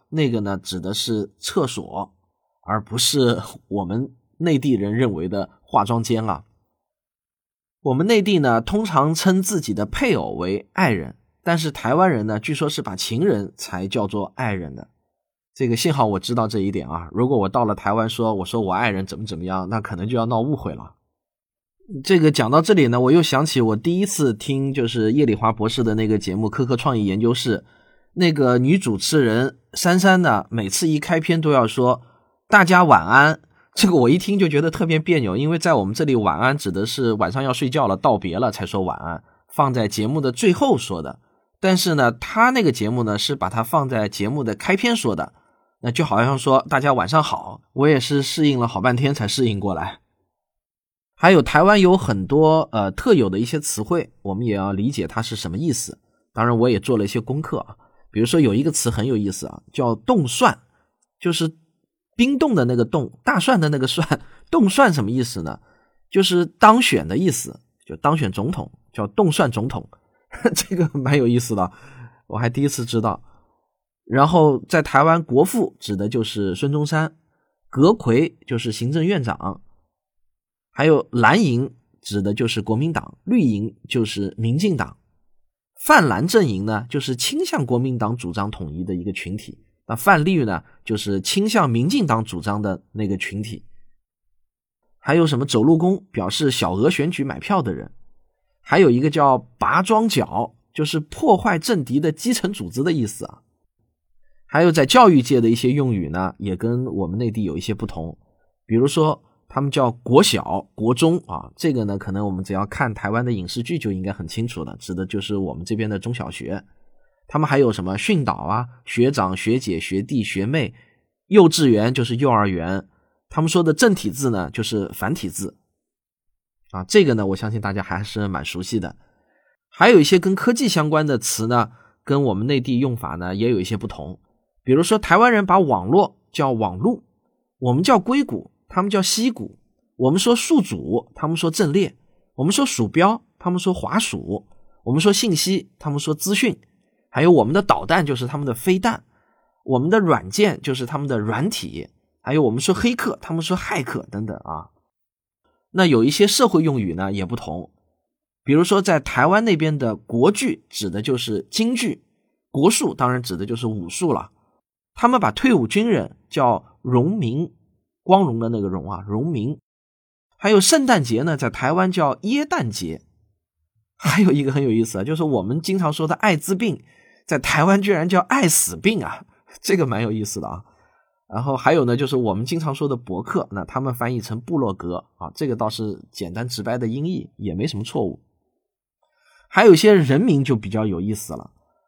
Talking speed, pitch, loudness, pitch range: 275 characters per minute, 125 Hz, -19 LUFS, 105-160 Hz